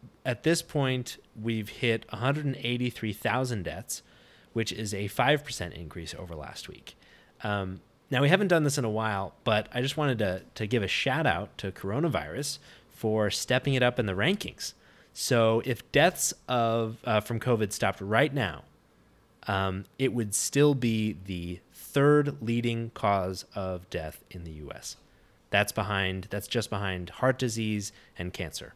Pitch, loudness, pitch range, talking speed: 110 Hz, -29 LUFS, 100-130 Hz, 160 wpm